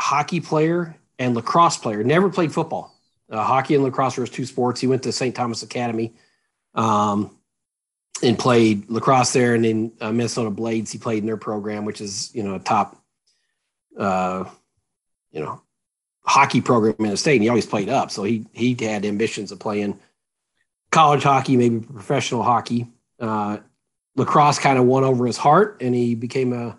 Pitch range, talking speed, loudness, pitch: 110-130 Hz, 180 wpm, -20 LUFS, 120 Hz